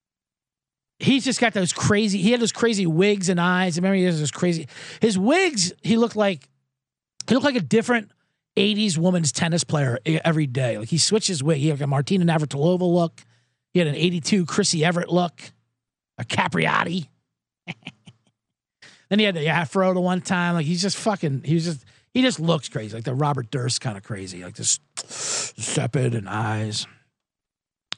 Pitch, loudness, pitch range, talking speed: 170 Hz, -22 LUFS, 140-195 Hz, 180 wpm